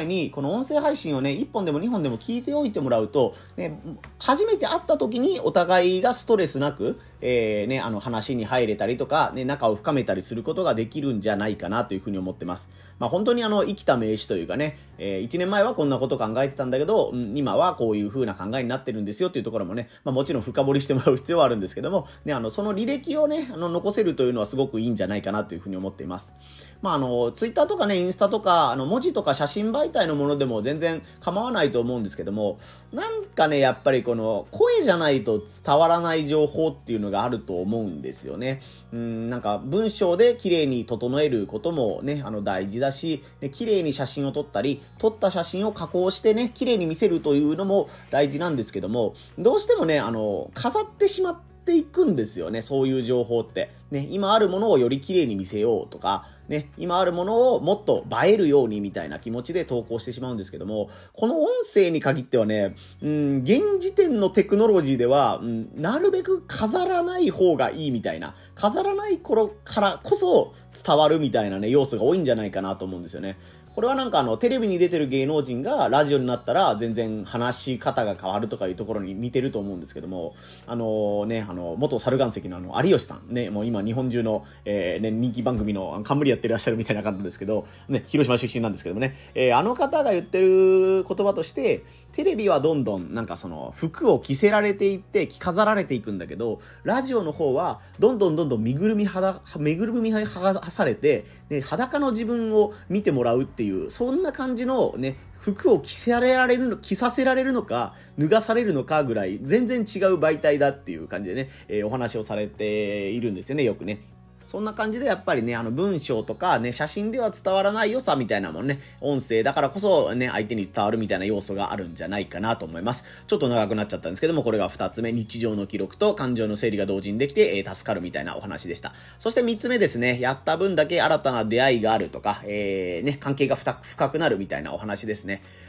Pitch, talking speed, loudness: 140 Hz, 430 characters per minute, -24 LUFS